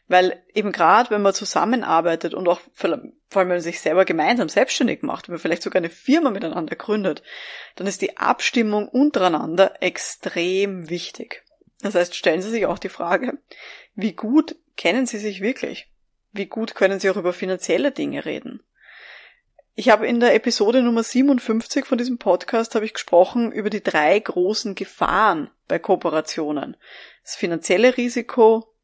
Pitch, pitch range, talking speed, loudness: 210 Hz, 185-240 Hz, 160 wpm, -20 LUFS